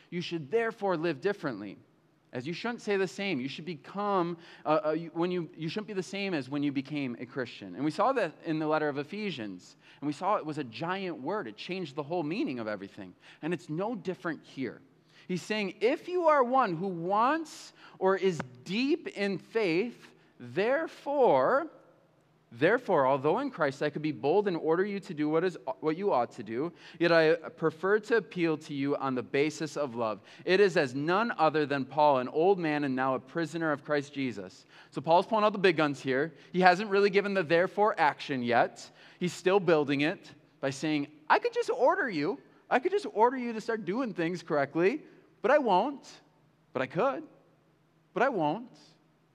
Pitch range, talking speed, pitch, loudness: 150-200 Hz, 205 wpm, 170 Hz, -30 LUFS